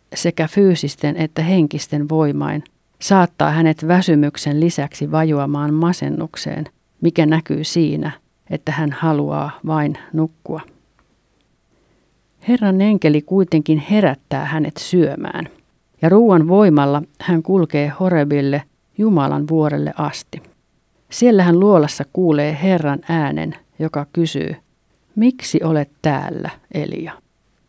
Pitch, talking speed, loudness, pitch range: 160 Hz, 100 wpm, -17 LUFS, 150-175 Hz